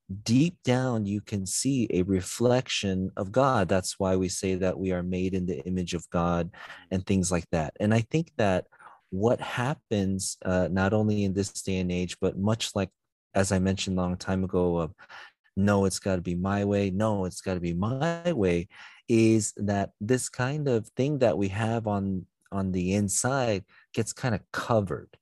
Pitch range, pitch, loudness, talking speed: 95-110 Hz, 95 Hz, -28 LUFS, 195 wpm